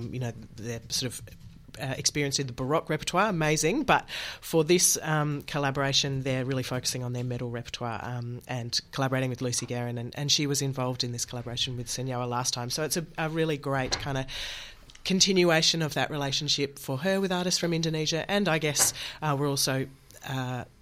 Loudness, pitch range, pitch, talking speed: -28 LUFS, 125-155 Hz, 135 Hz, 190 wpm